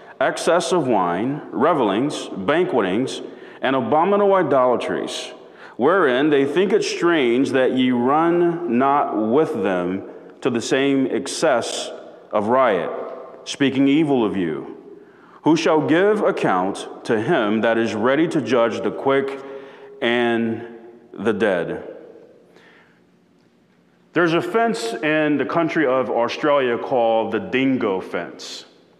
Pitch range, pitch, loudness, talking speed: 115-170 Hz, 135 Hz, -19 LUFS, 120 wpm